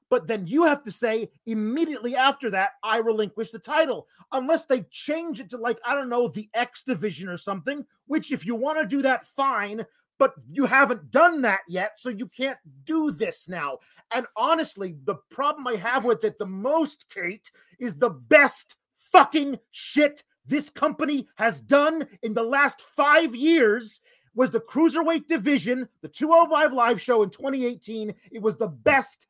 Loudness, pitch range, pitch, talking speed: -24 LUFS, 220-290 Hz, 255 Hz, 175 wpm